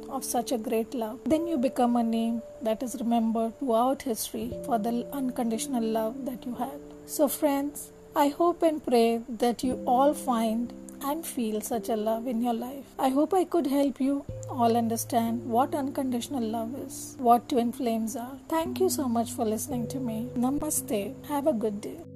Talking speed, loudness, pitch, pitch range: 185 wpm, -28 LUFS, 245 Hz, 230-280 Hz